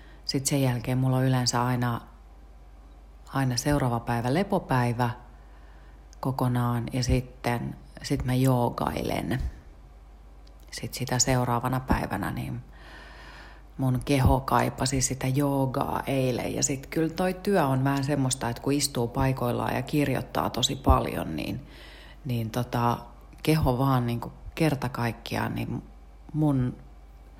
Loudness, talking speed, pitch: -27 LUFS, 120 wpm, 125 Hz